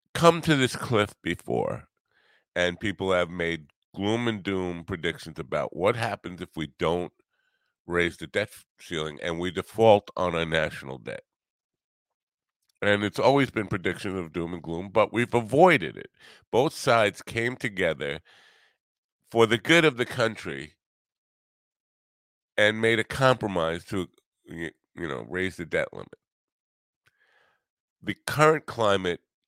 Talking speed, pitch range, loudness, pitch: 135 wpm, 85-115 Hz, -26 LUFS, 95 Hz